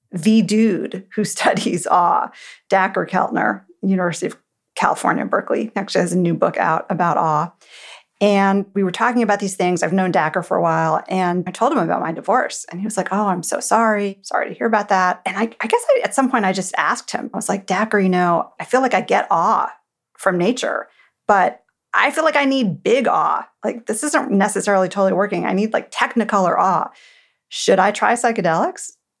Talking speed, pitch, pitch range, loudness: 210 wpm, 200 Hz, 185-225 Hz, -18 LUFS